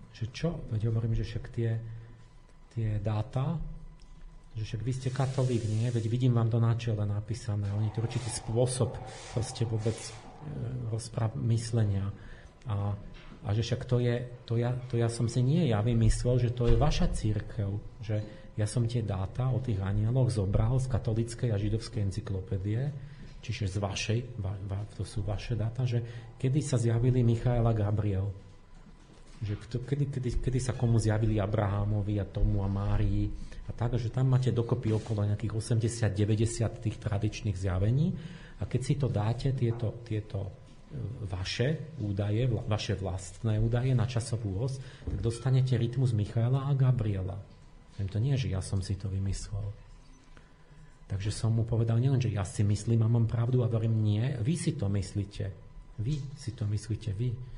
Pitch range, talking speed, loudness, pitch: 105-125 Hz, 165 wpm, -31 LUFS, 115 Hz